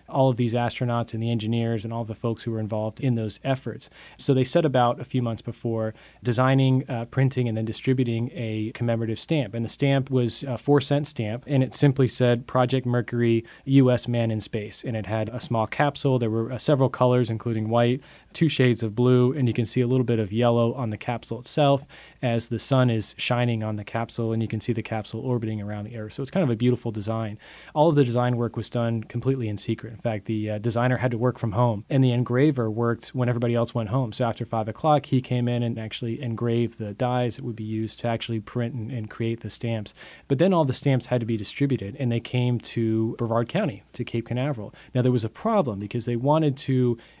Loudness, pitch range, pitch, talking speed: -25 LUFS, 115-130 Hz, 120 Hz, 240 wpm